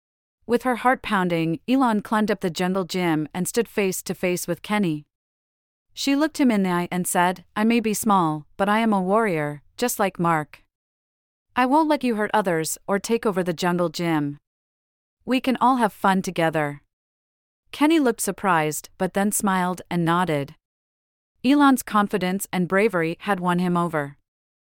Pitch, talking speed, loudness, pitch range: 180 Hz, 175 wpm, -22 LUFS, 155-215 Hz